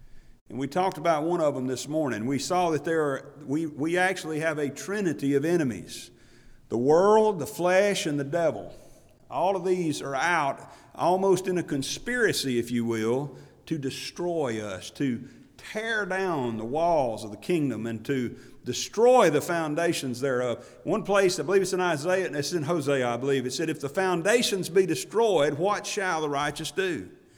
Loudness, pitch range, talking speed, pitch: -26 LUFS, 140-185 Hz, 180 wpm, 160 Hz